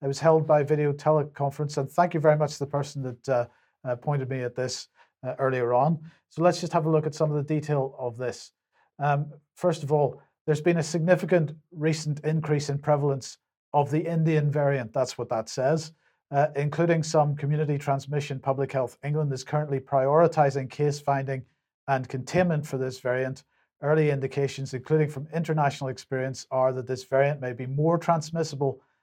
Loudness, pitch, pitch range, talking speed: -26 LUFS, 145 Hz, 135-155 Hz, 185 wpm